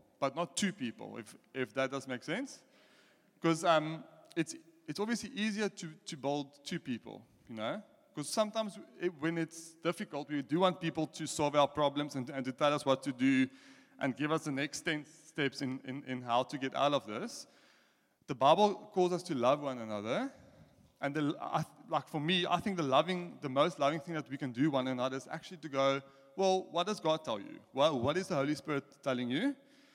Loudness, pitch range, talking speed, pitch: -35 LUFS, 140-185 Hz, 215 wpm, 155 Hz